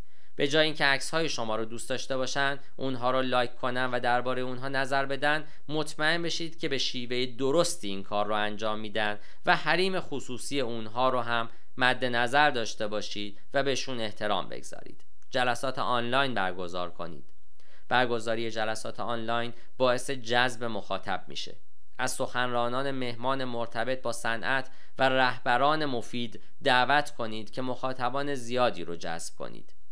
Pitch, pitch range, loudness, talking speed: 125 Hz, 115-135 Hz, -29 LUFS, 145 wpm